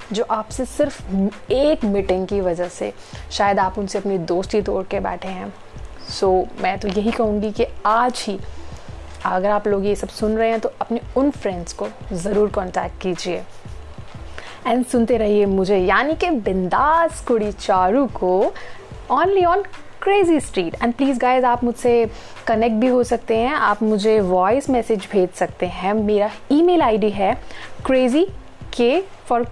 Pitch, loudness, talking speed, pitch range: 220 Hz, -19 LUFS, 165 wpm, 200-250 Hz